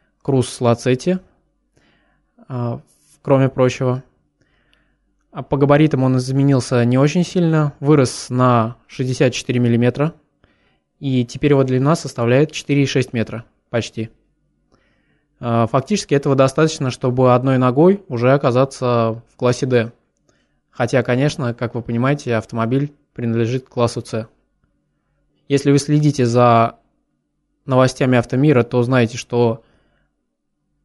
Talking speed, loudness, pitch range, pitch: 105 wpm, -17 LUFS, 120-140 Hz, 130 Hz